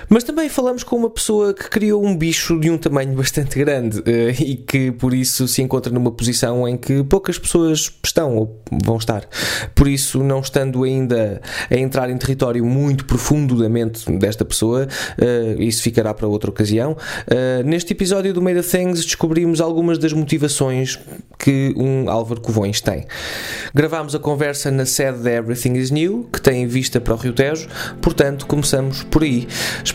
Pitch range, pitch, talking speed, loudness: 120-160 Hz, 135 Hz, 170 wpm, -18 LUFS